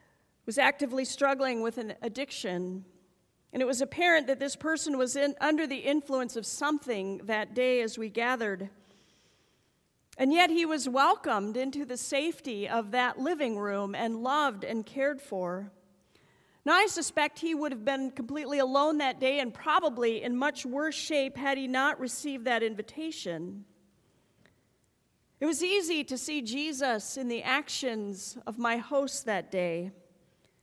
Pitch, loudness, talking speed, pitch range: 260 Hz, -30 LUFS, 155 wpm, 225-285 Hz